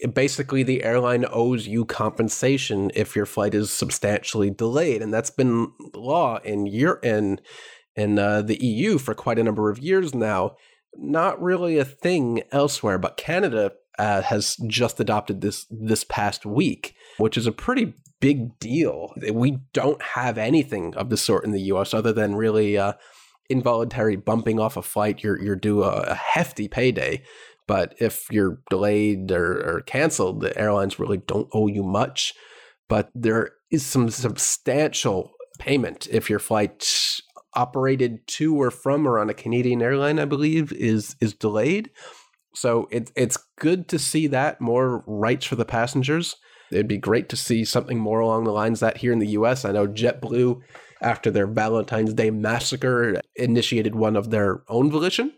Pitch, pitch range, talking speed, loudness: 115 Hz, 105-135 Hz, 165 wpm, -23 LUFS